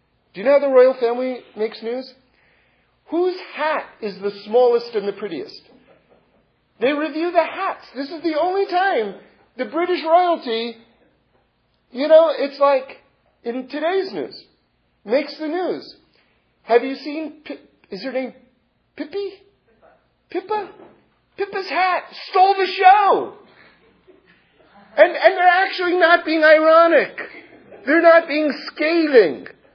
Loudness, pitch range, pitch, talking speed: -18 LUFS, 255-360 Hz, 310 Hz, 125 wpm